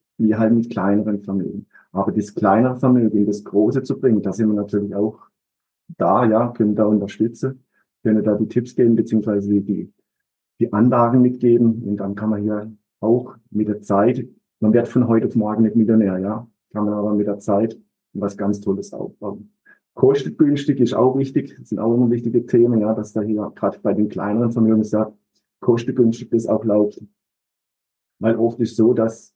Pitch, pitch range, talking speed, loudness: 110 Hz, 105-120 Hz, 180 wpm, -19 LUFS